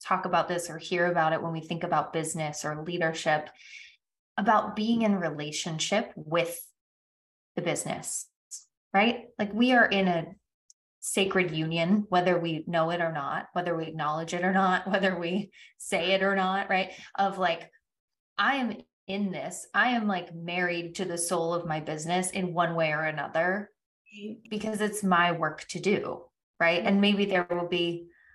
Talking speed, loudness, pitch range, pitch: 170 wpm, -28 LUFS, 165-195 Hz, 175 Hz